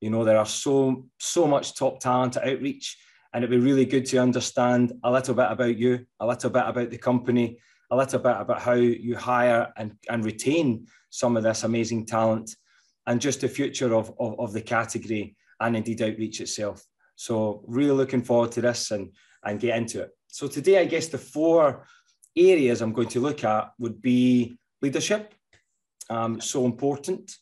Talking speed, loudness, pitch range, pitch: 185 wpm, -25 LUFS, 115-130 Hz, 120 Hz